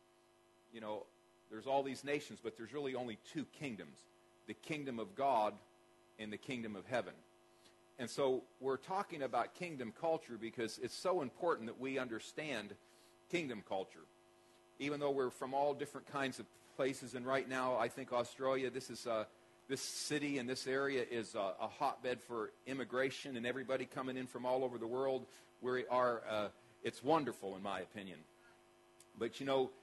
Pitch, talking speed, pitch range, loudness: 130 Hz, 170 wpm, 115-135 Hz, -41 LUFS